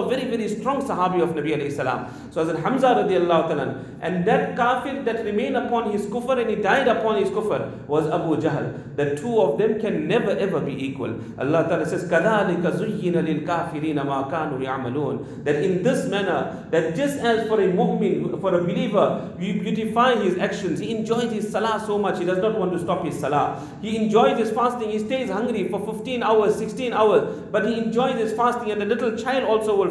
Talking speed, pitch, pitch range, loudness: 195 wpm, 210 Hz, 165-225 Hz, -22 LUFS